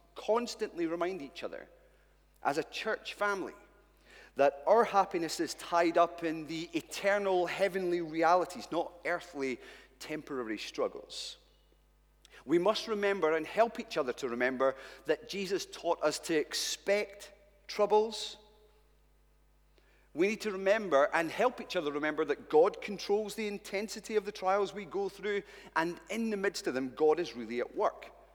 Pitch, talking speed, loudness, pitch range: 195 Hz, 150 wpm, -33 LUFS, 160-215 Hz